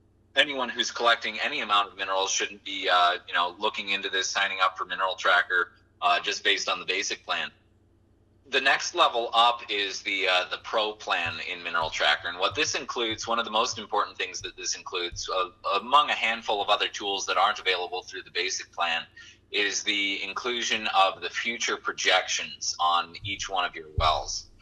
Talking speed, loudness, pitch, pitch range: 195 wpm, -26 LUFS, 100 Hz, 90-105 Hz